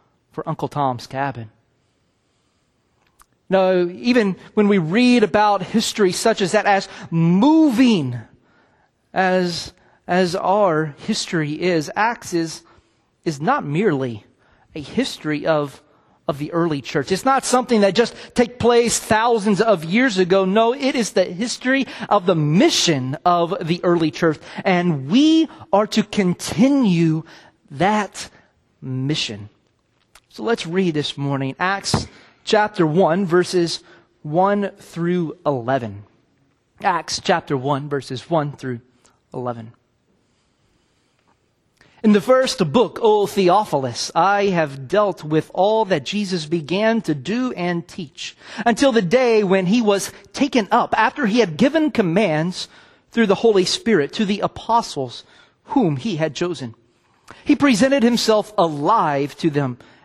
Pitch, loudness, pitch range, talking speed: 185 Hz, -19 LUFS, 150-220 Hz, 130 wpm